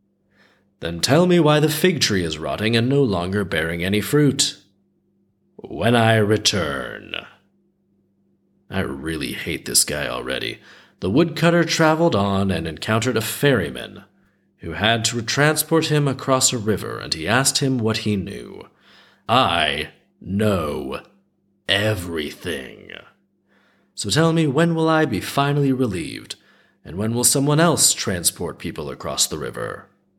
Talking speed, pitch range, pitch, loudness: 135 wpm, 95-150 Hz, 115 Hz, -20 LUFS